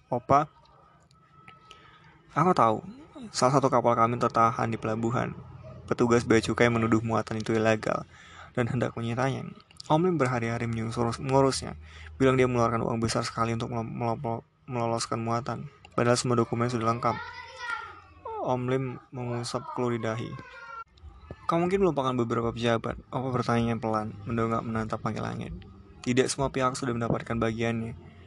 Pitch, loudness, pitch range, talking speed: 120 Hz, -28 LUFS, 115-130 Hz, 135 wpm